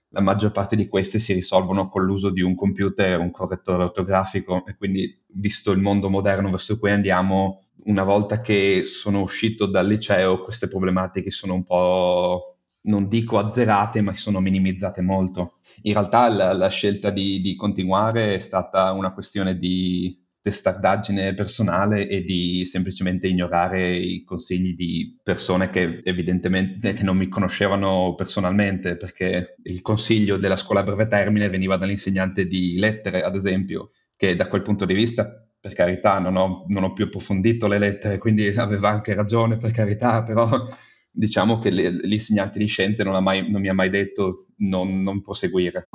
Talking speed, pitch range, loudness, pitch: 165 wpm, 95-105 Hz, -22 LUFS, 95 Hz